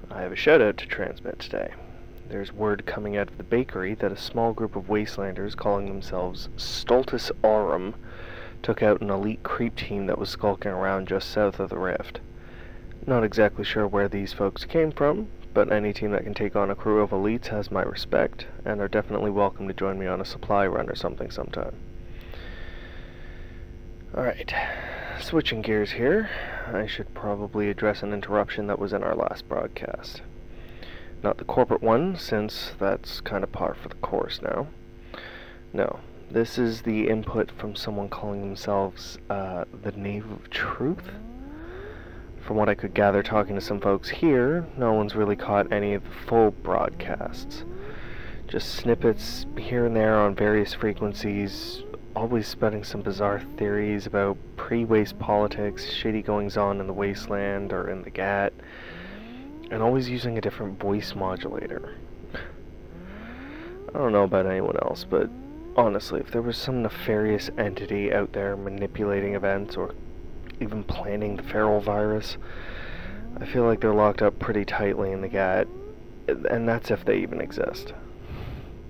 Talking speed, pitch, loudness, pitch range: 160 wpm, 105 Hz, -26 LUFS, 100-110 Hz